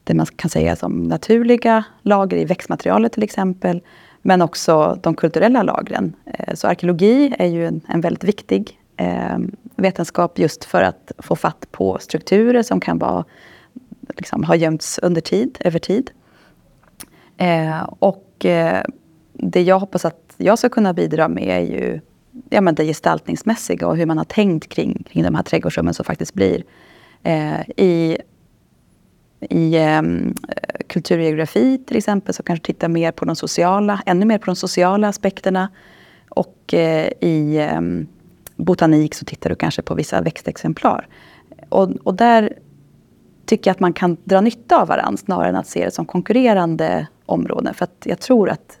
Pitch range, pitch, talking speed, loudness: 160-210 Hz, 180 Hz, 150 wpm, -18 LUFS